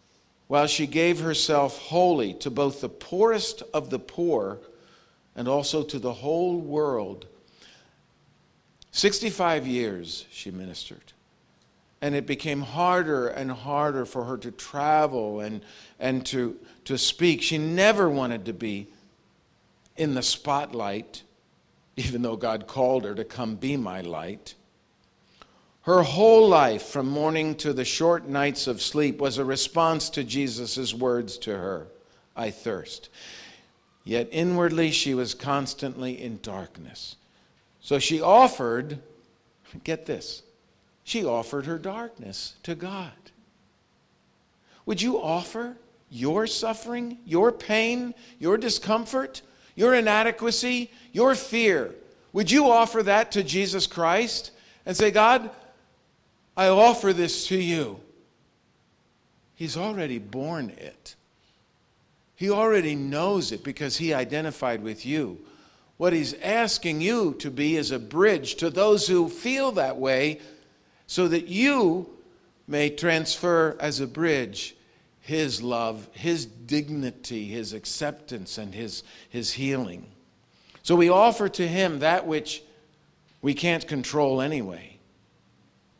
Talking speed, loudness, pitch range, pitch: 125 wpm, -25 LUFS, 130-185 Hz, 150 Hz